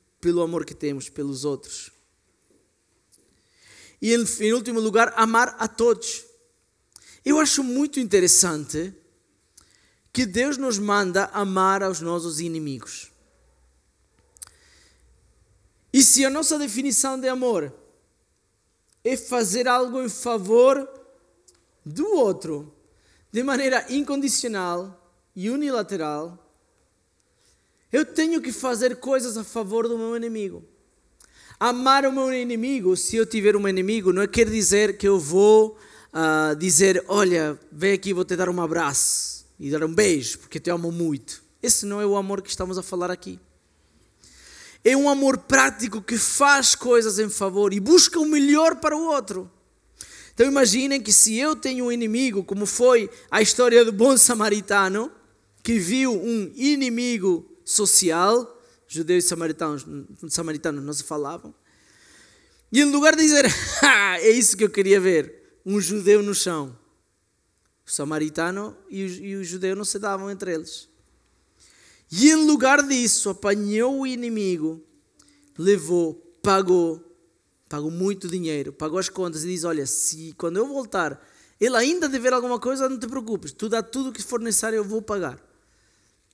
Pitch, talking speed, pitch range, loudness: 205 Hz, 145 wpm, 170-250 Hz, -20 LUFS